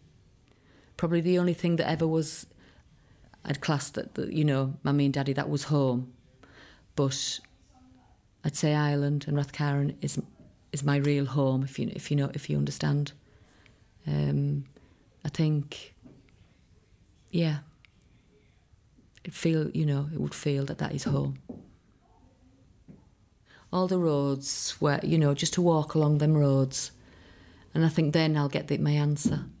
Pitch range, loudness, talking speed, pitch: 120-155 Hz, -28 LUFS, 150 wpm, 140 Hz